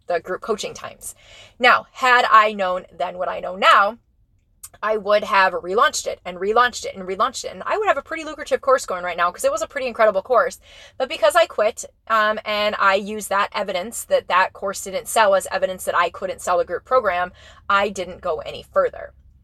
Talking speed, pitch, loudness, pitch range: 220 wpm, 210 Hz, -20 LUFS, 185-265 Hz